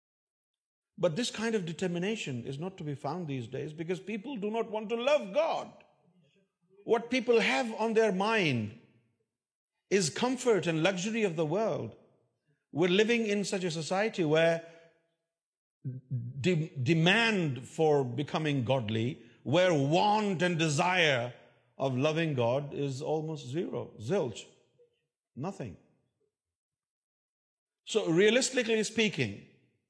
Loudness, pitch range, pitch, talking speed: -30 LUFS, 140-215 Hz, 175 Hz, 90 wpm